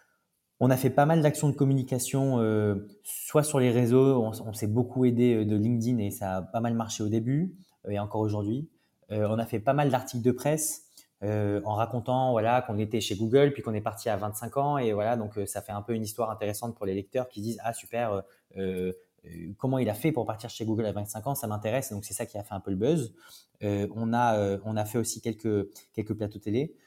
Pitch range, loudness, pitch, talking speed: 105-125 Hz, -28 LUFS, 115 Hz, 250 wpm